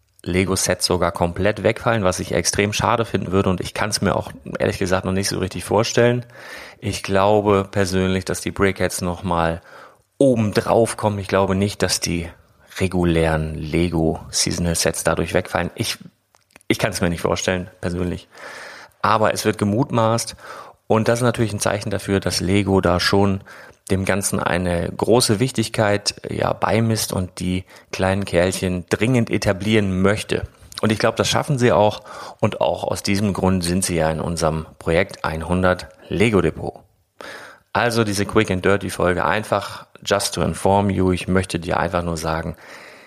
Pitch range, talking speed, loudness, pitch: 90-105 Hz, 165 wpm, -20 LUFS, 95 Hz